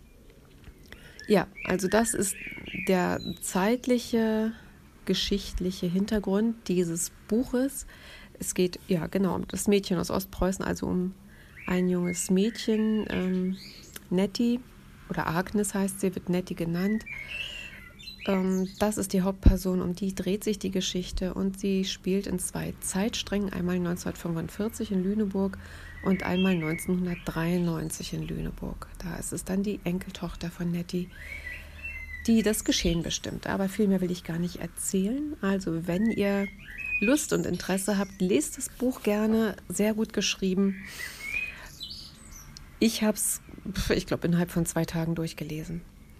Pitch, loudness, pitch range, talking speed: 185 Hz, -29 LUFS, 170-205 Hz, 130 wpm